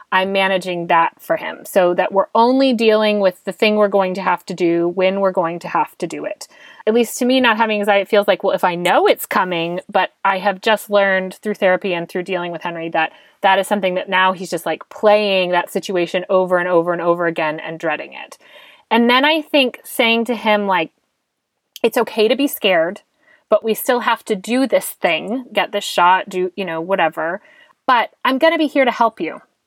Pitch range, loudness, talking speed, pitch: 180-230 Hz, -17 LUFS, 230 wpm, 195 Hz